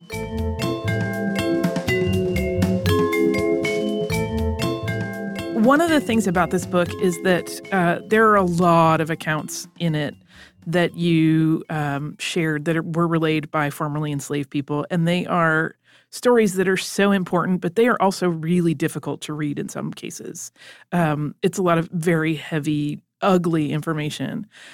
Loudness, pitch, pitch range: -21 LUFS, 160 Hz, 135-175 Hz